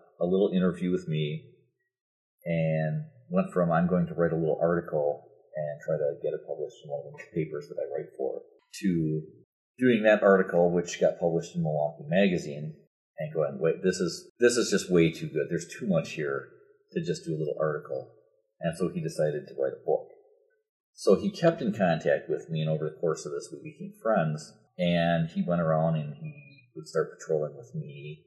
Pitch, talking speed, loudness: 120 Hz, 205 wpm, -28 LUFS